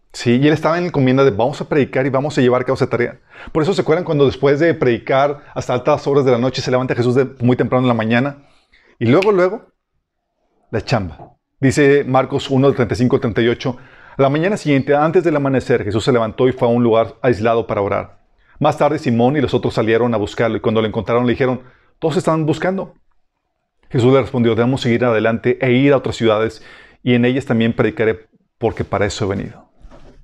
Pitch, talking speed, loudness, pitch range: 130 Hz, 210 wpm, -16 LUFS, 120-140 Hz